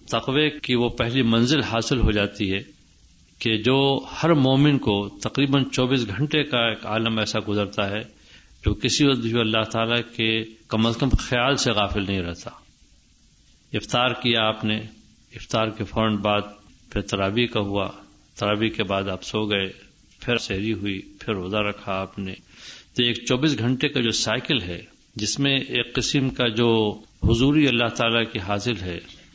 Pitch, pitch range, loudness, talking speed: 110 Hz, 100-125 Hz, -23 LUFS, 170 wpm